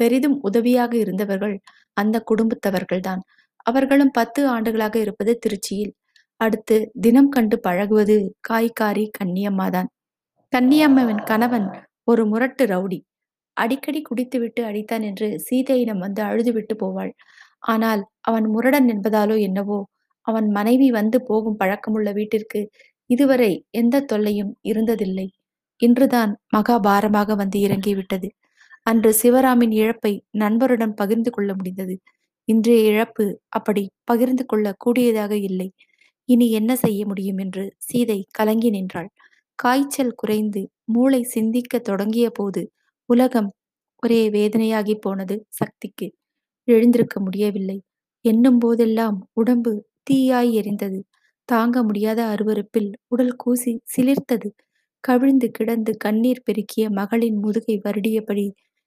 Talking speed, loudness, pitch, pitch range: 105 wpm, -20 LUFS, 220 Hz, 205-240 Hz